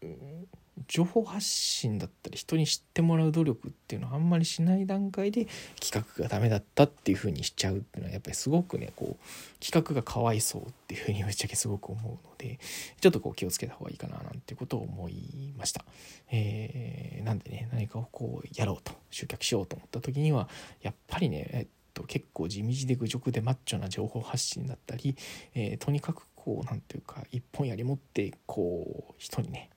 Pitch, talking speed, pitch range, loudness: 135 Hz, 410 characters per minute, 115-155 Hz, -32 LUFS